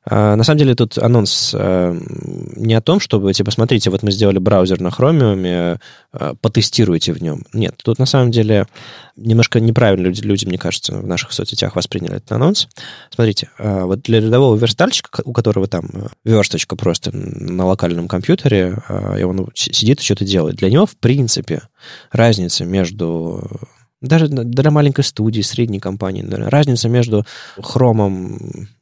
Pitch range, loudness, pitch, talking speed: 95-130 Hz, -15 LUFS, 115 Hz, 160 wpm